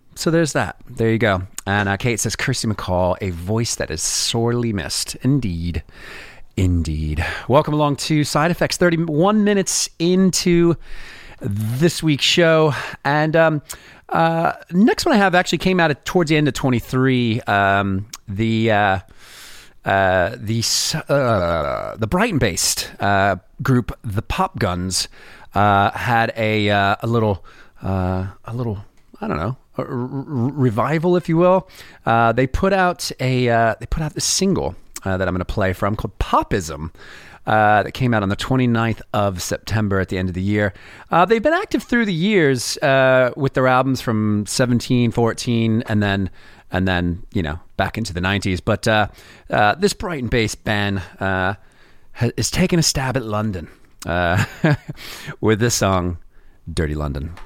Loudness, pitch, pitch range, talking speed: -19 LUFS, 115 Hz, 100-145 Hz, 165 wpm